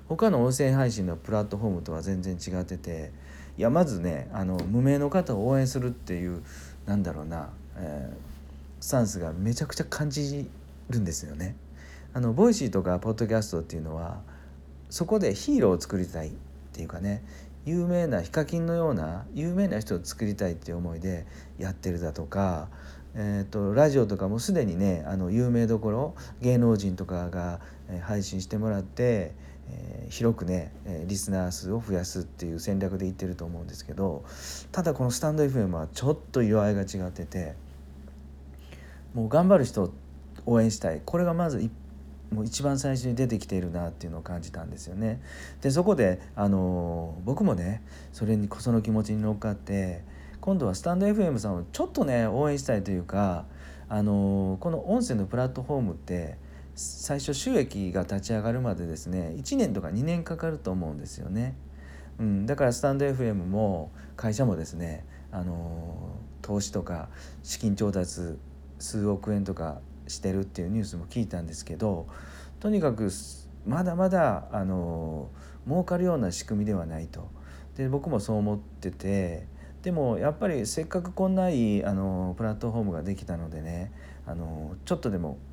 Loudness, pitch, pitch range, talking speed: -29 LUFS, 95 Hz, 80-115 Hz, 320 characters per minute